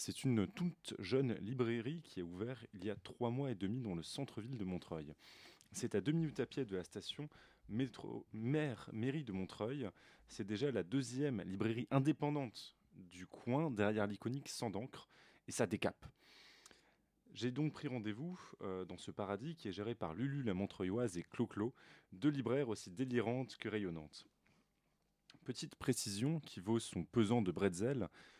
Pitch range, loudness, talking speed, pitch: 100-140 Hz, -42 LUFS, 165 wpm, 120 Hz